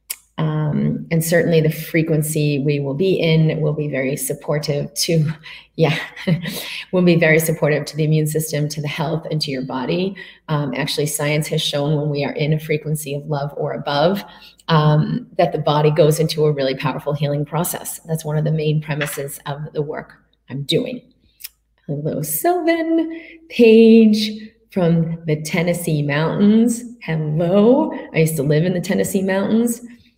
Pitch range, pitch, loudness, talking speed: 150-180 Hz, 155 Hz, -18 LUFS, 165 wpm